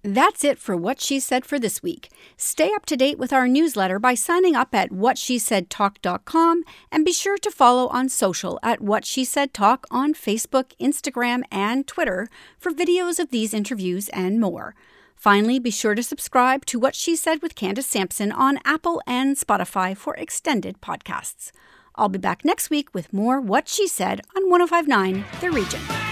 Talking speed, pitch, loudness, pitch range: 180 wpm, 260 Hz, -21 LUFS, 210-315 Hz